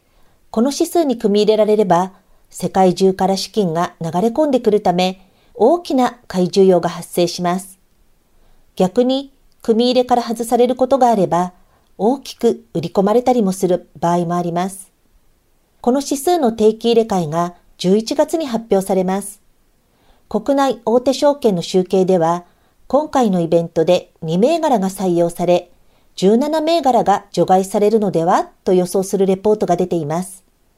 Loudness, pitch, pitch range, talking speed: -16 LUFS, 200 Hz, 180-245 Hz, 295 characters per minute